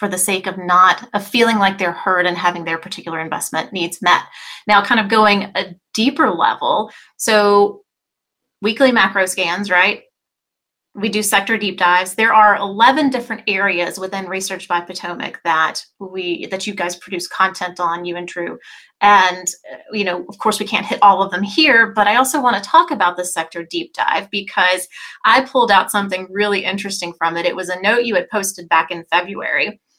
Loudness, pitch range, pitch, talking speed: -16 LUFS, 180-210 Hz, 195 Hz, 190 wpm